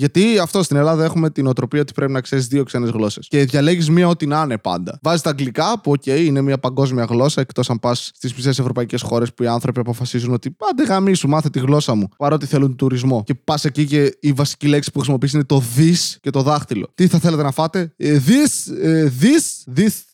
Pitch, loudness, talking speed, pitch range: 145 Hz, -17 LUFS, 225 wpm, 130-160 Hz